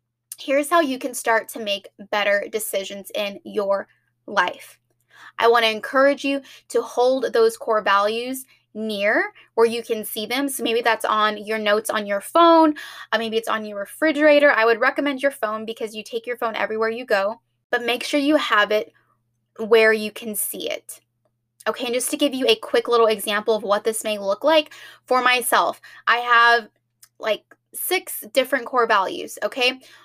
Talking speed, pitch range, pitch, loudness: 185 wpm, 210-265 Hz, 230 Hz, -20 LUFS